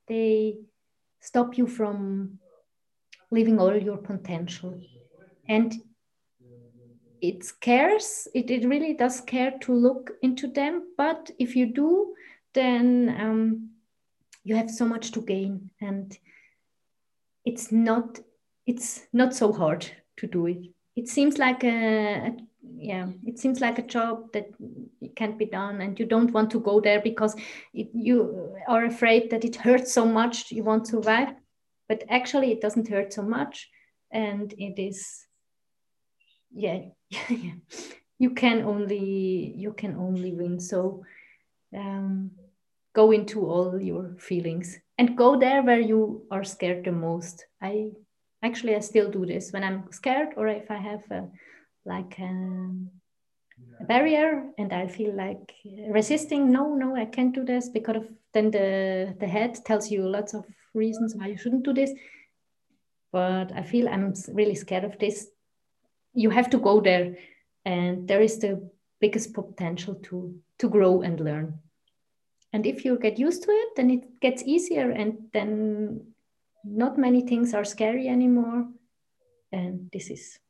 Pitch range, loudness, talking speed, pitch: 195-245 Hz, -26 LUFS, 150 wpm, 220 Hz